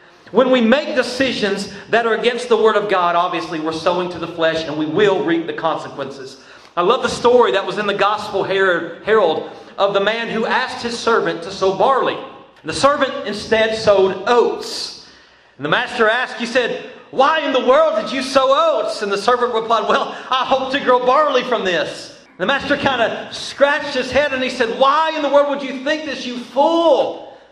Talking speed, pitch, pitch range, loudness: 205 wpm, 235 Hz, 195-270 Hz, -17 LUFS